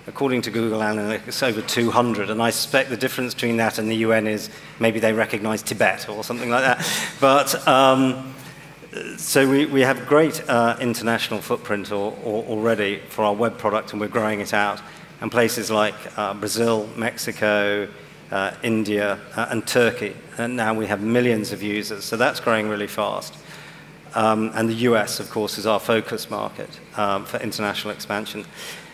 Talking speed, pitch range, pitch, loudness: 175 wpm, 105-120 Hz, 110 Hz, -21 LUFS